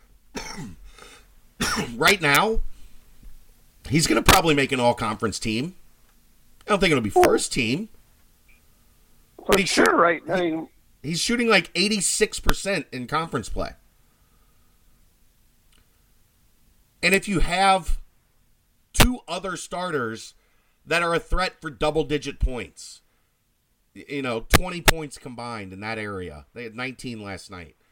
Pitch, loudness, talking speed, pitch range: 140 Hz, -22 LUFS, 125 wpm, 115-175 Hz